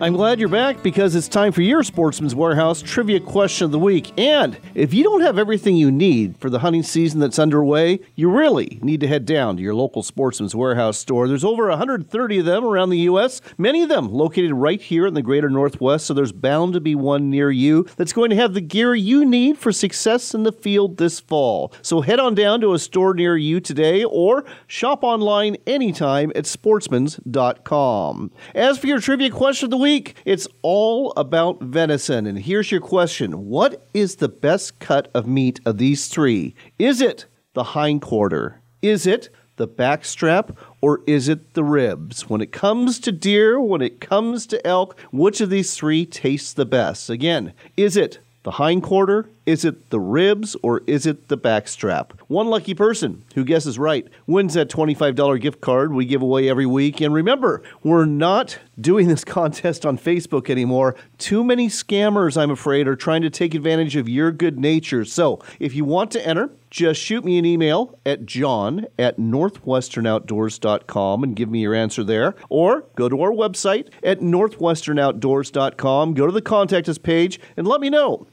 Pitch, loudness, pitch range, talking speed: 165 Hz, -19 LUFS, 140-205 Hz, 190 wpm